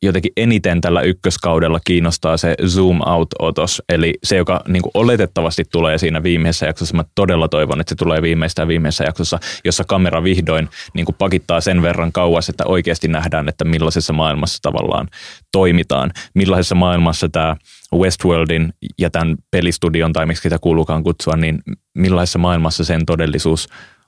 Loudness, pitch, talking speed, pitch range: -16 LUFS, 85 Hz, 150 wpm, 80-90 Hz